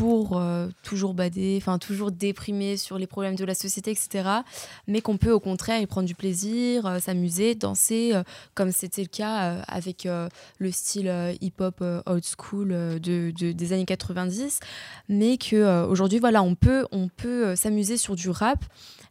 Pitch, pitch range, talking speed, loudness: 190 Hz, 180-215 Hz, 190 wpm, -26 LUFS